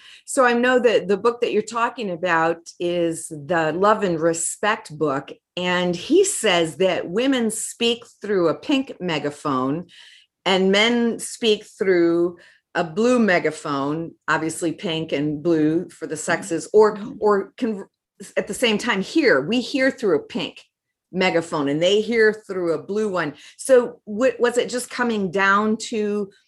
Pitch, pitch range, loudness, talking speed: 195 Hz, 165-230 Hz, -21 LUFS, 155 wpm